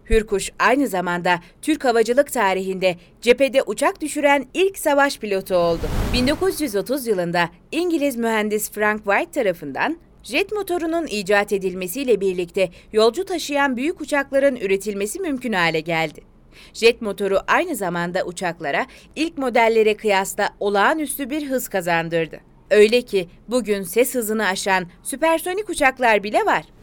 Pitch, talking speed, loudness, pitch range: 220 Hz, 125 wpm, -20 LUFS, 190-280 Hz